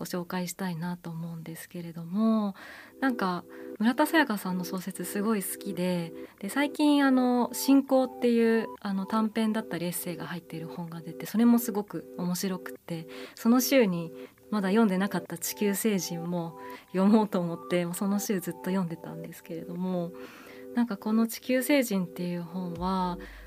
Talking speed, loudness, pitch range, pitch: 350 characters per minute, -28 LUFS, 175-225 Hz, 190 Hz